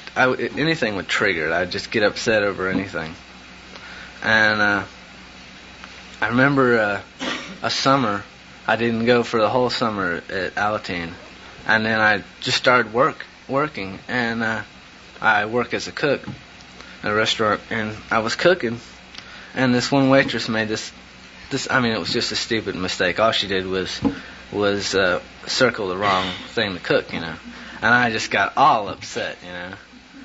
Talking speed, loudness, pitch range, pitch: 170 wpm, -20 LUFS, 90-115 Hz, 105 Hz